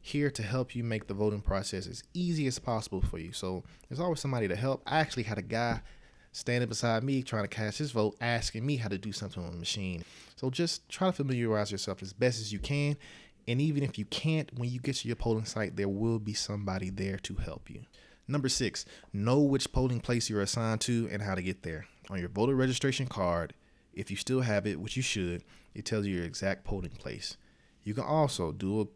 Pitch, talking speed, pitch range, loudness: 110 Hz, 230 wpm, 100-130 Hz, -33 LUFS